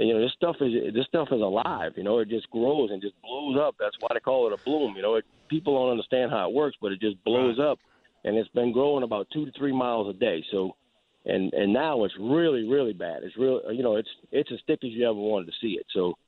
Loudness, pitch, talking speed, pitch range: -27 LUFS, 125 Hz, 275 wpm, 110-150 Hz